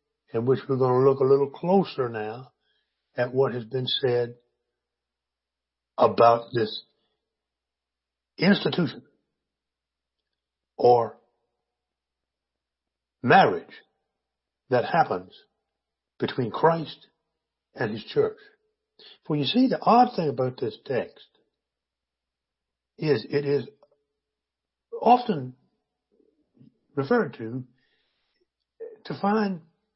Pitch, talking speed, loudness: 125 Hz, 90 wpm, -24 LUFS